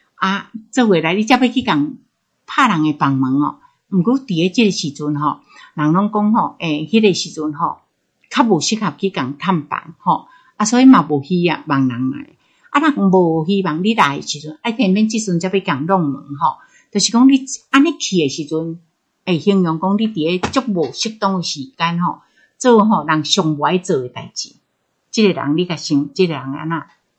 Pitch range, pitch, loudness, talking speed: 155-225 Hz, 185 Hz, -16 LUFS, 275 characters per minute